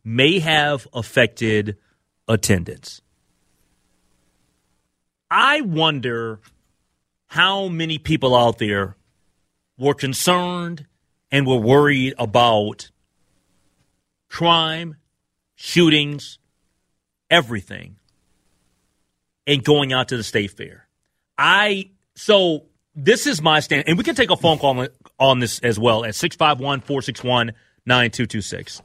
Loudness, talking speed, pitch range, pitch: -18 LUFS, 95 wpm, 100-150 Hz, 125 Hz